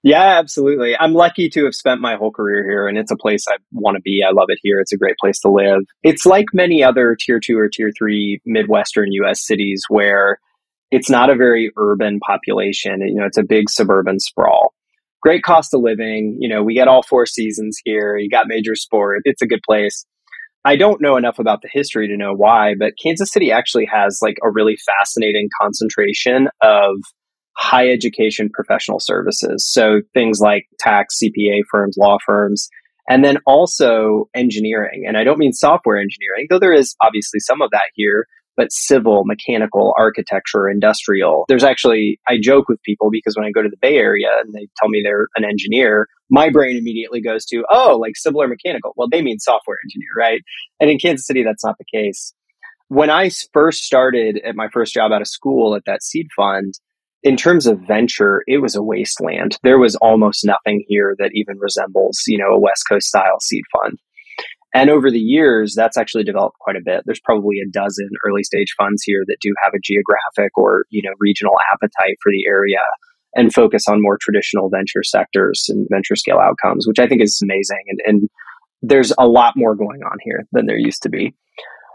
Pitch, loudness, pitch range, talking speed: 110 Hz, -14 LUFS, 105-130 Hz, 200 wpm